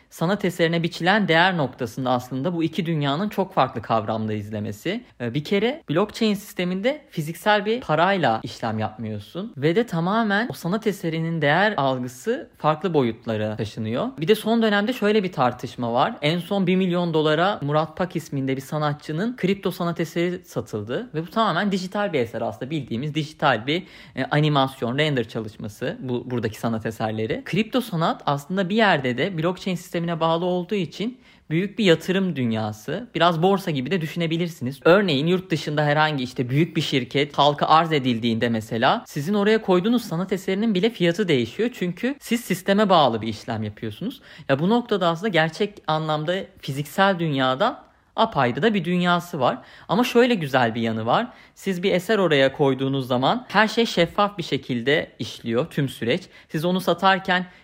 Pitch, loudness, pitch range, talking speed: 165 Hz, -23 LUFS, 135-195 Hz, 160 wpm